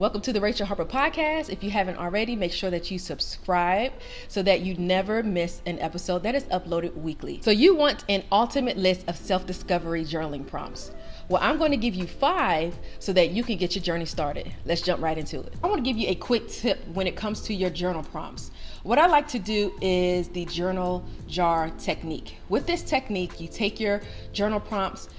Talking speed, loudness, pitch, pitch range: 215 wpm, -26 LUFS, 185 Hz, 175-215 Hz